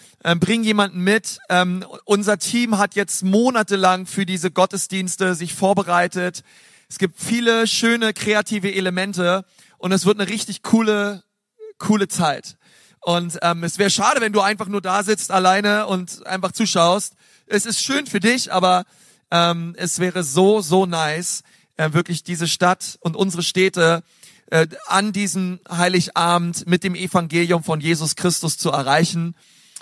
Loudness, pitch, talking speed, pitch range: -19 LUFS, 185 Hz, 150 wpm, 175-205 Hz